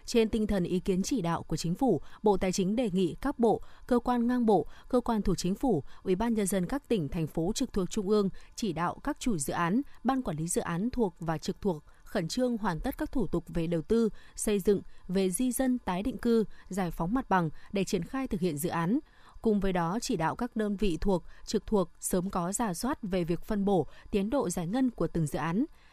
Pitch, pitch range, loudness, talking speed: 200 Hz, 180-235 Hz, -31 LUFS, 250 wpm